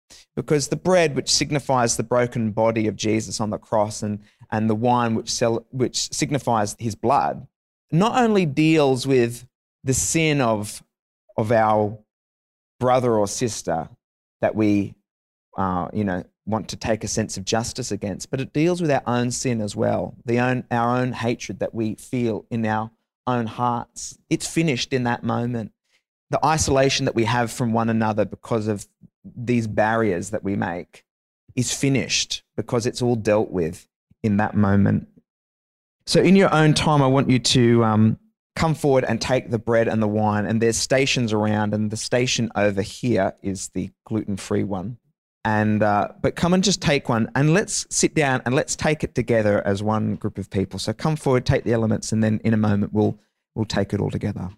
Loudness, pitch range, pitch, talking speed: -22 LUFS, 105-130 Hz, 115 Hz, 190 wpm